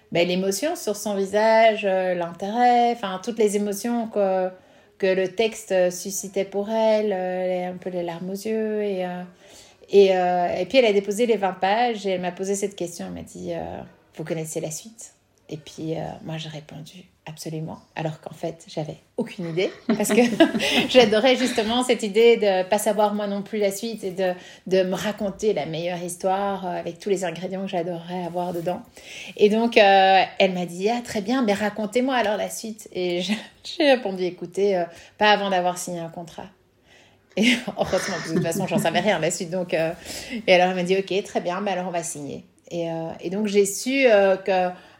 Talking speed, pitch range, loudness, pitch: 205 wpm, 180-215 Hz, -22 LUFS, 195 Hz